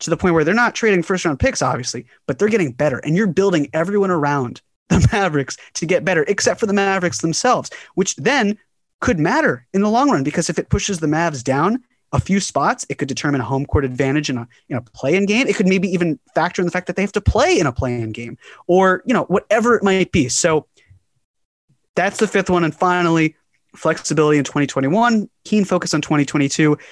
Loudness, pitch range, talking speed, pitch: -18 LUFS, 140-195 Hz, 220 wpm, 165 Hz